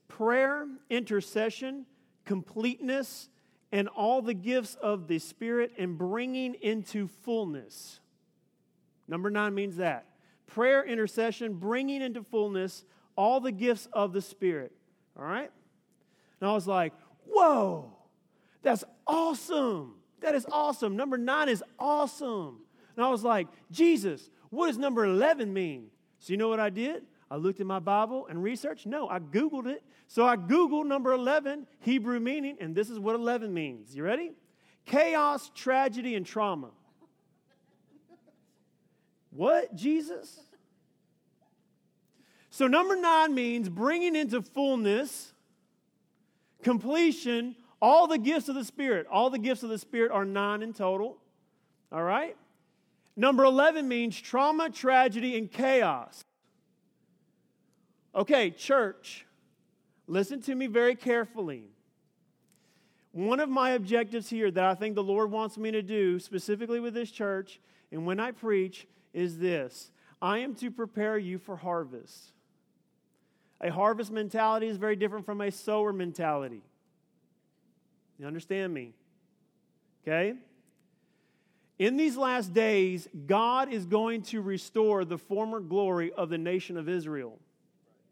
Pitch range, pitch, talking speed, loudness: 195-255 Hz, 220 Hz, 135 wpm, -29 LUFS